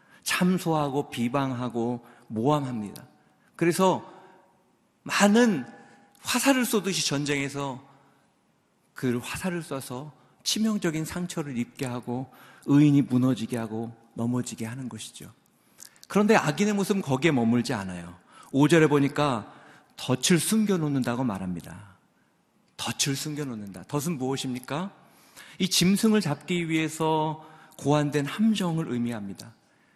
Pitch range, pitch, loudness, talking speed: 125-175 Hz, 145 Hz, -26 LUFS, 265 characters per minute